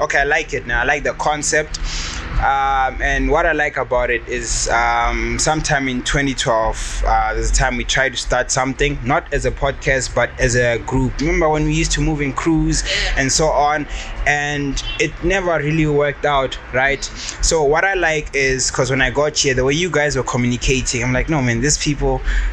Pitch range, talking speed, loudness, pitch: 125-150 Hz, 210 wpm, -17 LUFS, 135 Hz